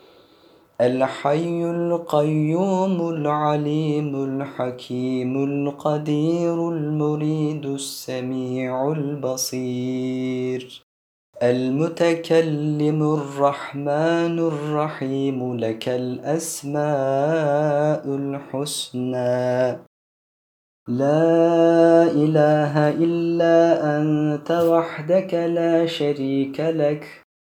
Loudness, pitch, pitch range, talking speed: -21 LUFS, 150 Hz, 130-160 Hz, 50 wpm